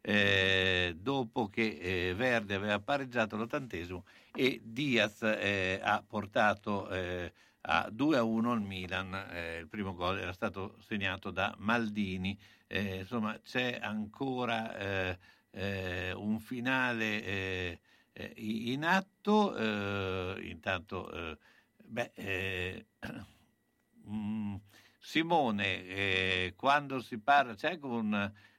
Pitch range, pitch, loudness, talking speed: 95-115 Hz, 105 Hz, -33 LUFS, 110 wpm